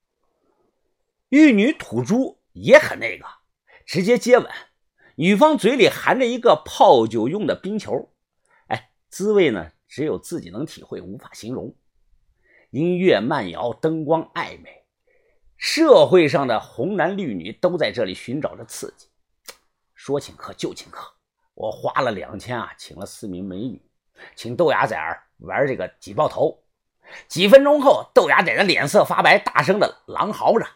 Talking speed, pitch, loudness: 220 characters per minute, 250 Hz, -19 LUFS